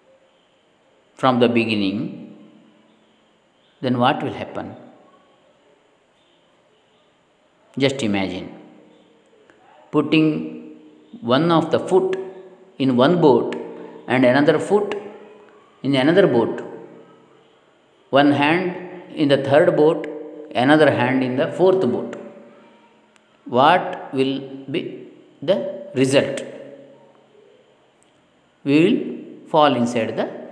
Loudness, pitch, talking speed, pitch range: -19 LUFS, 150 Hz, 90 wpm, 130-190 Hz